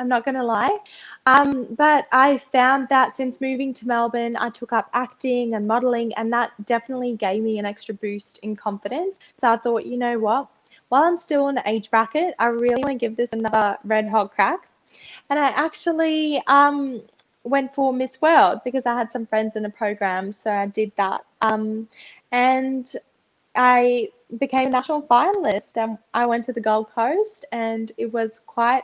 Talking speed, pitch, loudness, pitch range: 190 wpm, 240 Hz, -21 LUFS, 220-270 Hz